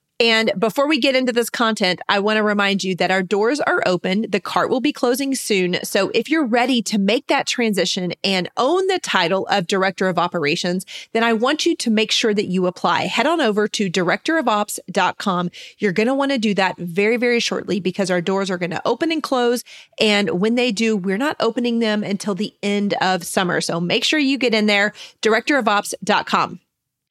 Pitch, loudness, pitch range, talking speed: 210 Hz, -19 LUFS, 190-245 Hz, 210 wpm